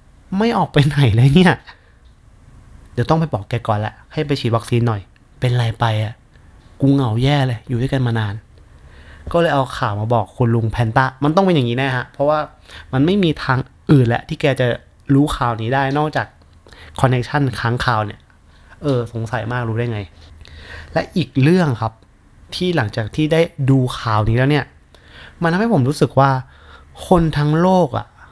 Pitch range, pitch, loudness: 110-145 Hz, 120 Hz, -17 LUFS